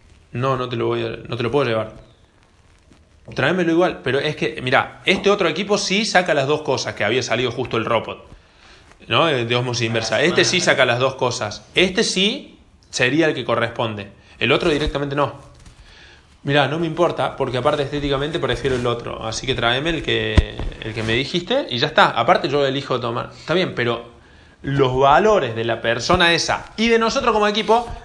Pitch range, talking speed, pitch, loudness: 115-165 Hz, 195 wpm, 130 Hz, -19 LUFS